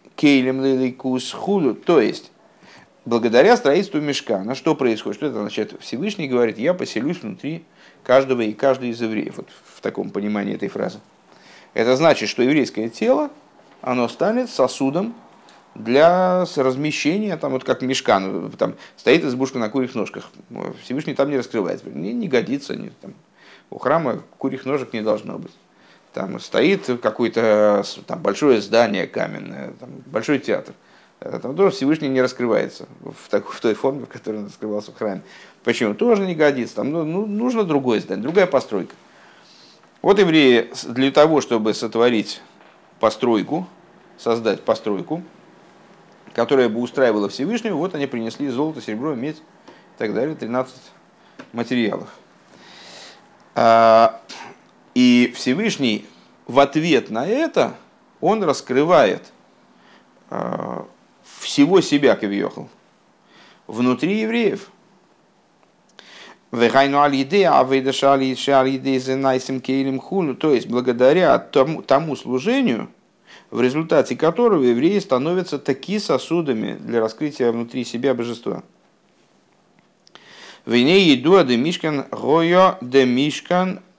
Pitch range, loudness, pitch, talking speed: 120-170 Hz, -19 LUFS, 135 Hz, 115 wpm